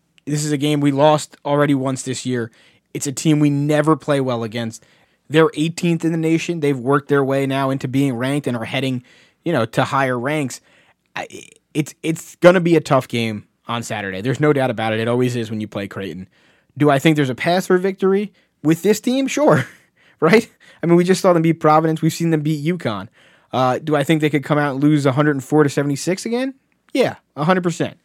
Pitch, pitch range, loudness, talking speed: 145 Hz, 130-160 Hz, -18 LUFS, 220 wpm